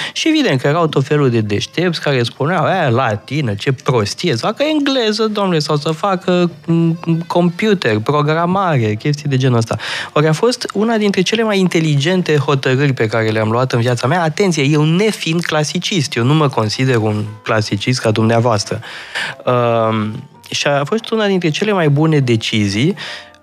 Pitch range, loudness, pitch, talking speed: 120-180 Hz, -15 LUFS, 150 Hz, 165 wpm